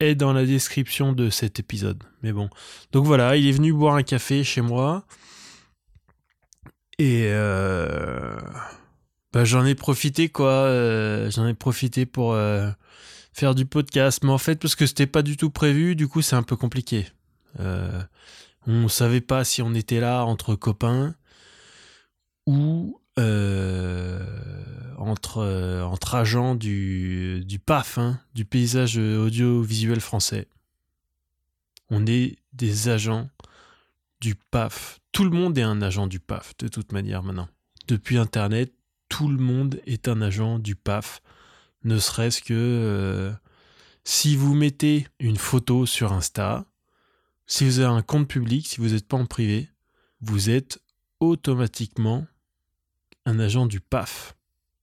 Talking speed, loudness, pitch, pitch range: 145 wpm, -23 LUFS, 120 Hz, 105-135 Hz